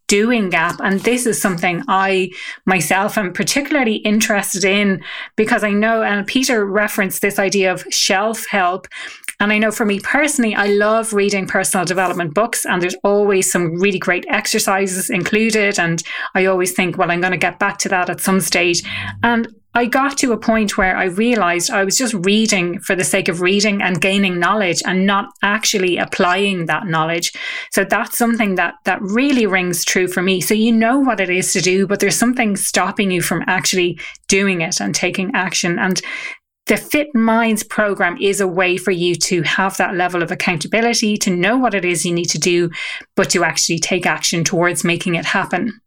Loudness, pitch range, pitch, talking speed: -16 LUFS, 180-215 Hz, 195 Hz, 195 wpm